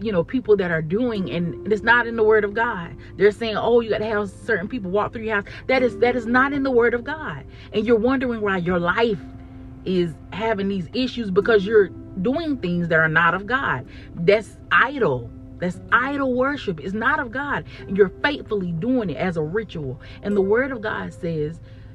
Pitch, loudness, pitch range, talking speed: 210 Hz, -21 LUFS, 175-235 Hz, 215 wpm